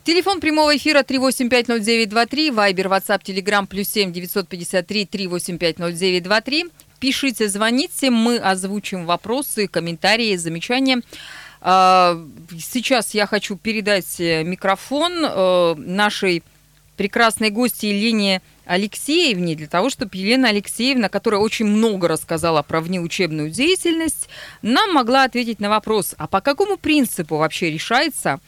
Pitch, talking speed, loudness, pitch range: 205 Hz, 105 wpm, -18 LUFS, 180-250 Hz